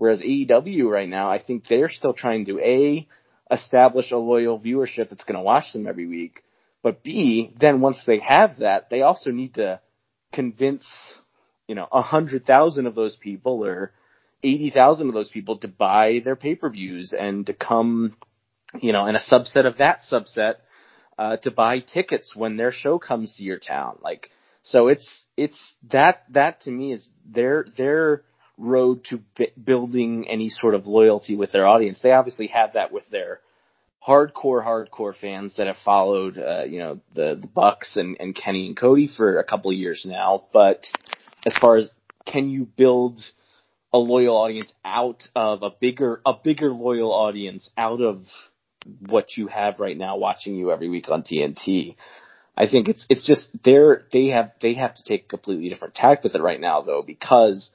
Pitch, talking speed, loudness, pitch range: 120 Hz, 185 wpm, -20 LUFS, 105-130 Hz